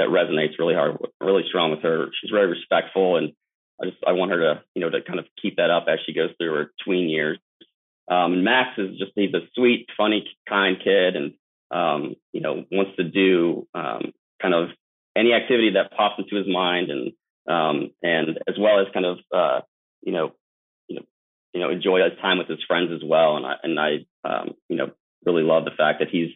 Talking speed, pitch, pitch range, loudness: 220 wpm, 95 Hz, 90-105 Hz, -22 LUFS